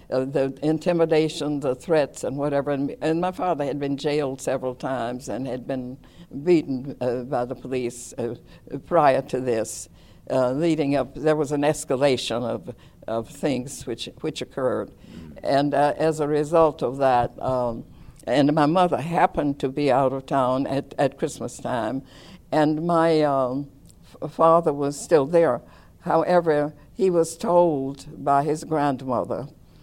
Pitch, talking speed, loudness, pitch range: 140 Hz, 155 wpm, -23 LUFS, 130-155 Hz